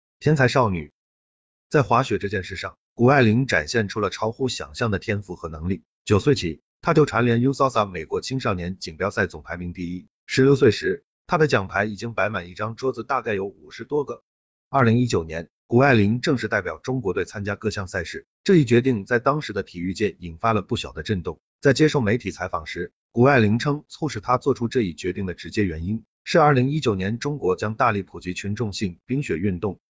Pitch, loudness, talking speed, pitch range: 110 Hz, -23 LUFS, 325 characters per minute, 95-130 Hz